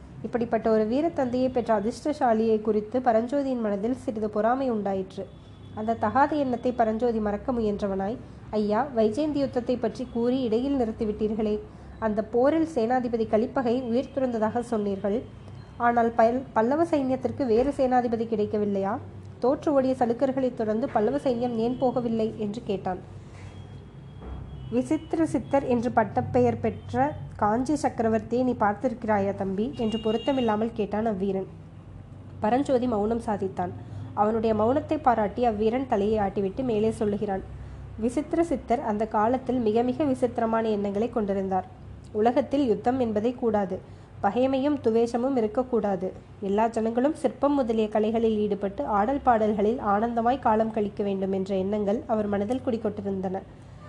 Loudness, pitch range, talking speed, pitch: -26 LUFS, 210-250 Hz, 120 wpm, 225 Hz